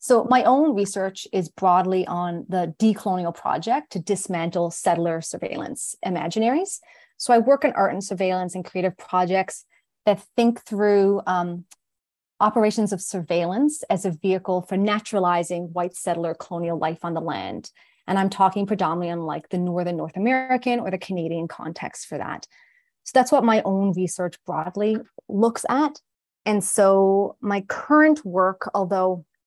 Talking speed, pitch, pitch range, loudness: 155 wpm, 190 Hz, 175-220 Hz, -23 LUFS